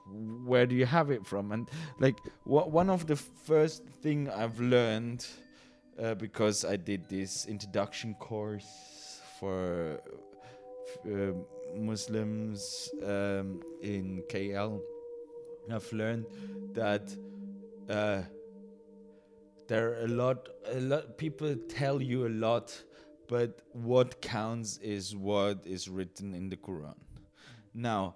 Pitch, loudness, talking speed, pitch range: 115 Hz, -33 LUFS, 115 wpm, 100-150 Hz